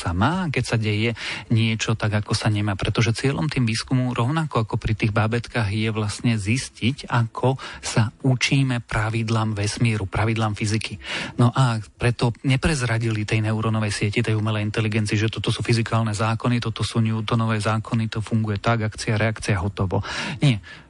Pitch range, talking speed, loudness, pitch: 110-120 Hz, 155 wpm, -23 LUFS, 115 Hz